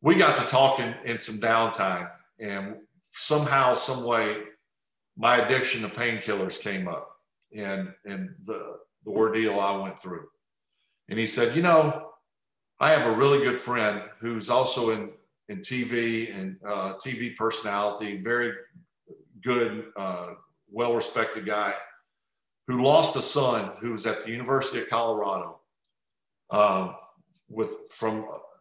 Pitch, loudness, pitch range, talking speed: 115 Hz, -26 LUFS, 105-135 Hz, 135 wpm